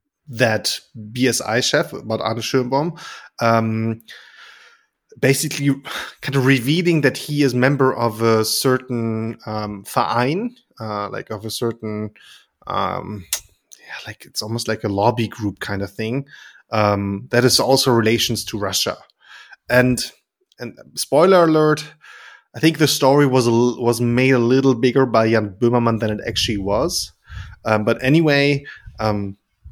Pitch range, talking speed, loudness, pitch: 110-135 Hz, 135 wpm, -18 LUFS, 115 Hz